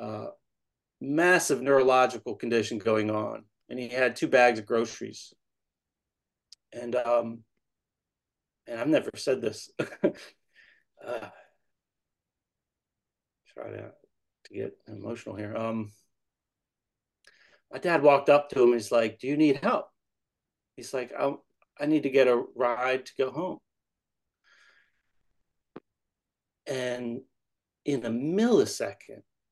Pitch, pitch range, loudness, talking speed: 120 Hz, 115-135 Hz, -27 LUFS, 115 wpm